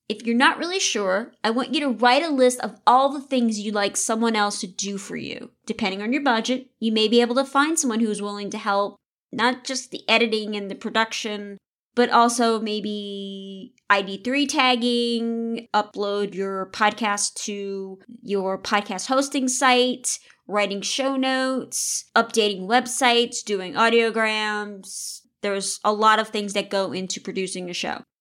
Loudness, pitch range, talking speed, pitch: -22 LUFS, 205-250 Hz, 165 wpm, 220 Hz